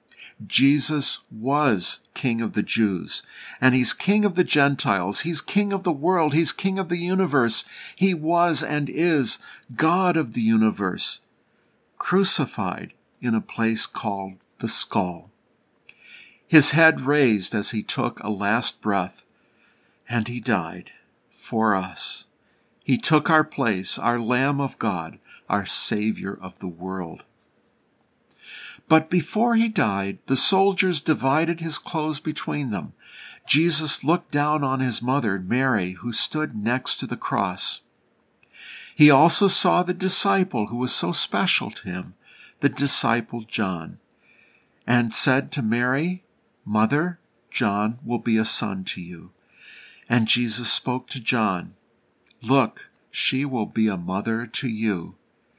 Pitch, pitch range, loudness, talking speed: 135 Hz, 110-160 Hz, -23 LUFS, 135 wpm